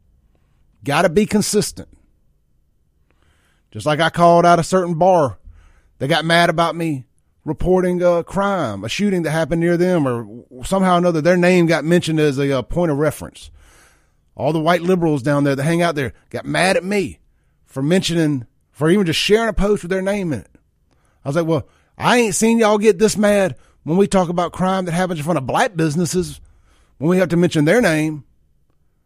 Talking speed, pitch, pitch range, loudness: 195 wpm, 165 Hz, 120-180 Hz, -17 LUFS